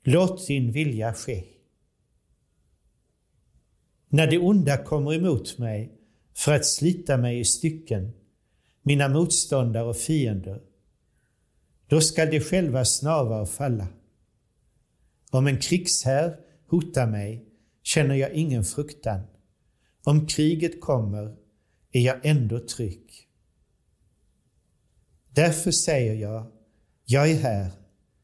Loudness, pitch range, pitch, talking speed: -24 LUFS, 110-155 Hz, 130 Hz, 105 wpm